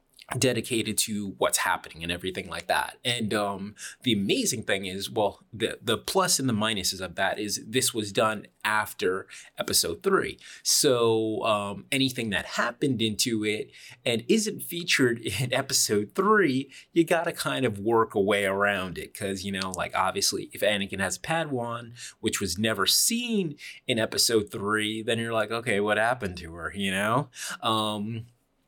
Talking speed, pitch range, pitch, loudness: 165 wpm, 100-130 Hz, 110 Hz, -26 LUFS